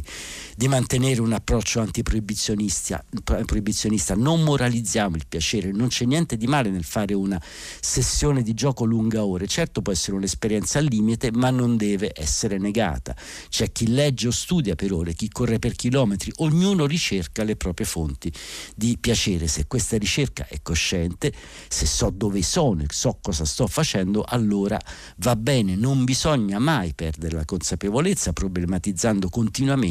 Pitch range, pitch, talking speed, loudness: 90-120 Hz, 105 Hz, 155 wpm, -23 LUFS